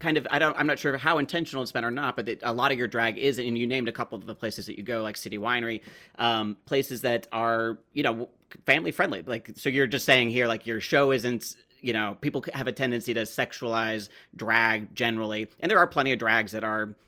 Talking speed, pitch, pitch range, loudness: 250 wpm, 120 Hz, 115-135 Hz, -27 LUFS